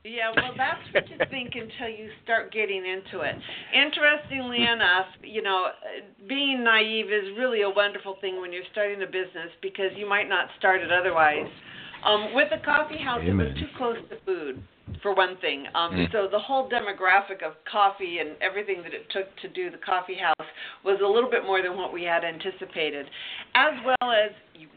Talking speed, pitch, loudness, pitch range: 195 wpm, 205 Hz, -25 LUFS, 185-240 Hz